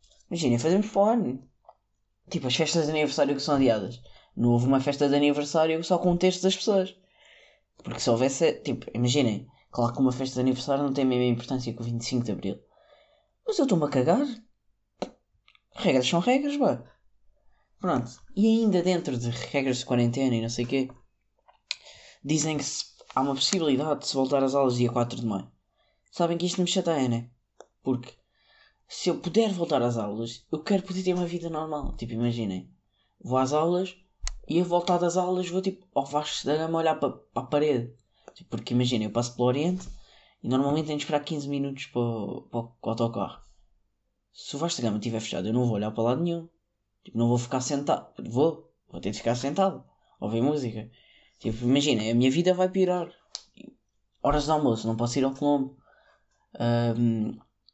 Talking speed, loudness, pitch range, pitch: 190 wpm, -27 LUFS, 120-170 Hz, 135 Hz